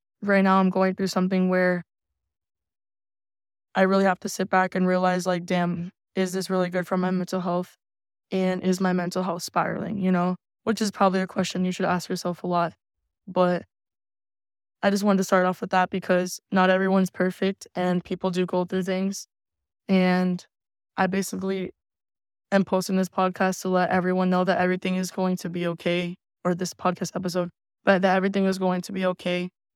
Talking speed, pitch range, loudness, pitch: 190 wpm, 180-190 Hz, -25 LUFS, 185 Hz